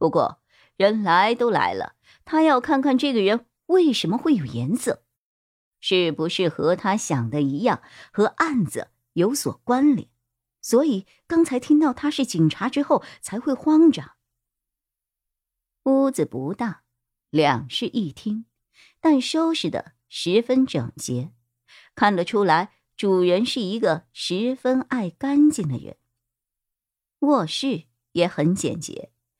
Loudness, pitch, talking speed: -22 LUFS, 205 Hz, 185 characters per minute